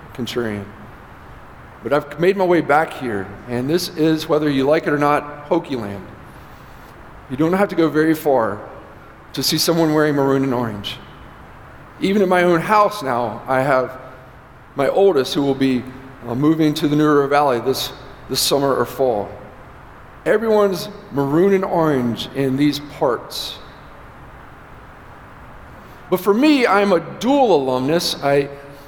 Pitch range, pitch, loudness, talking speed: 130-165 Hz, 145 Hz, -18 LUFS, 150 wpm